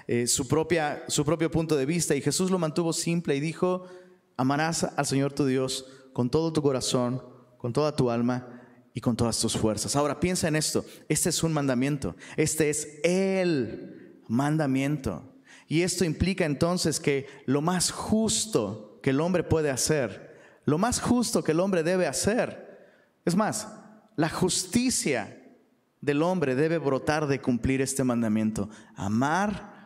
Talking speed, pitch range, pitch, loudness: 160 wpm, 130-175 Hz, 150 Hz, -27 LUFS